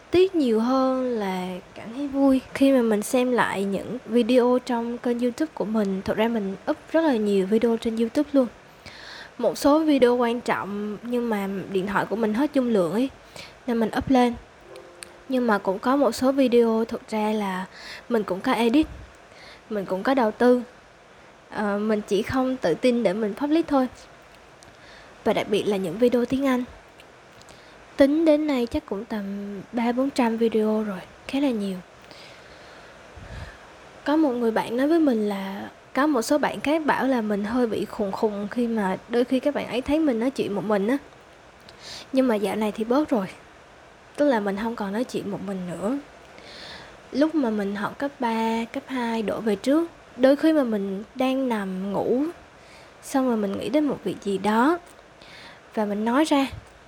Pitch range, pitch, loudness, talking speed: 210-265 Hz, 235 Hz, -24 LUFS, 190 wpm